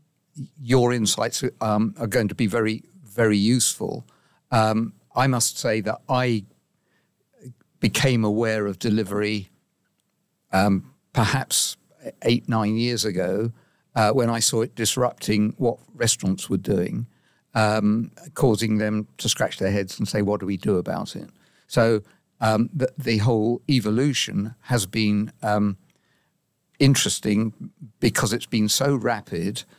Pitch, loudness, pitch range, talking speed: 110 Hz, -23 LUFS, 105-125 Hz, 135 wpm